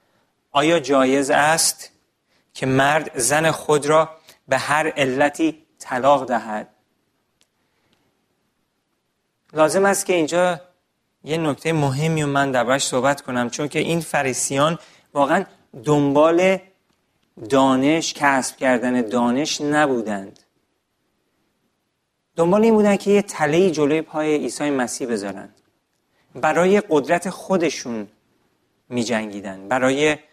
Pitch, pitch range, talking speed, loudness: 150 Hz, 130-160 Hz, 105 wpm, -19 LUFS